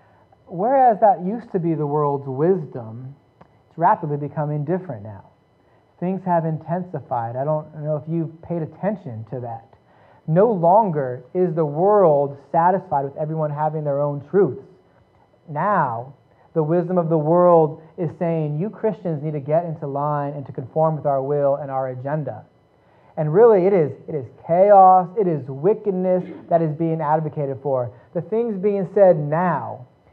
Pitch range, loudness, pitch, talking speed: 140-180 Hz, -20 LUFS, 155 Hz, 160 wpm